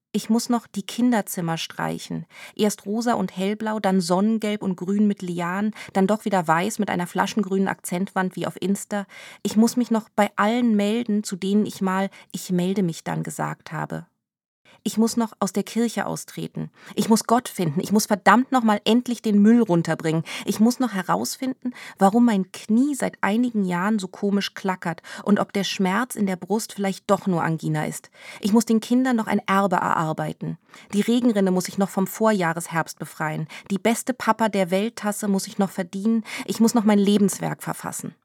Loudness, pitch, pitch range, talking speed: -23 LUFS, 200 Hz, 185-220 Hz, 190 wpm